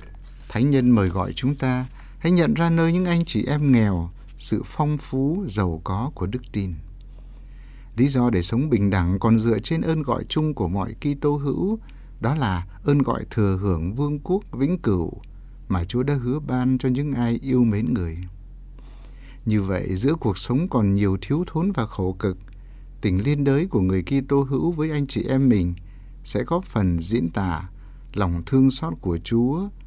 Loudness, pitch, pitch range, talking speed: -23 LUFS, 125 Hz, 100-140 Hz, 190 wpm